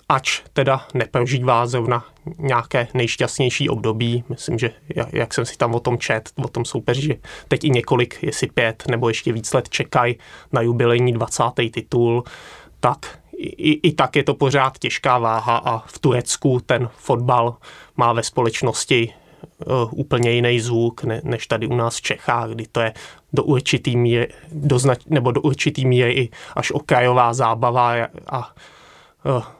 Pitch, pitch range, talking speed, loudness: 125 Hz, 115-135 Hz, 160 wpm, -20 LUFS